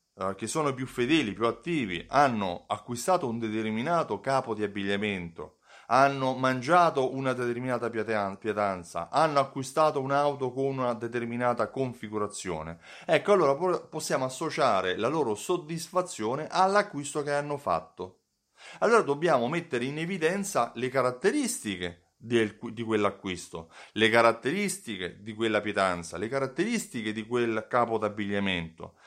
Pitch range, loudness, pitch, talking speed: 105-145 Hz, -28 LUFS, 120 Hz, 120 wpm